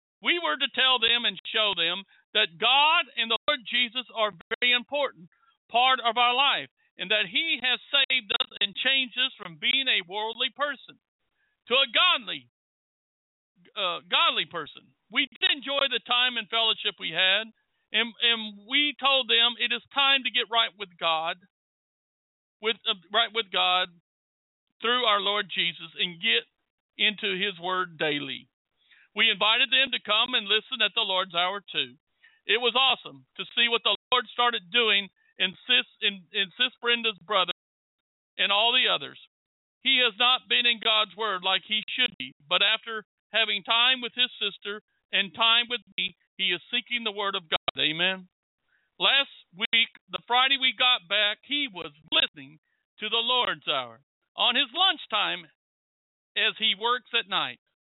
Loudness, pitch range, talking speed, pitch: -24 LUFS, 195-250 Hz, 170 wpm, 225 Hz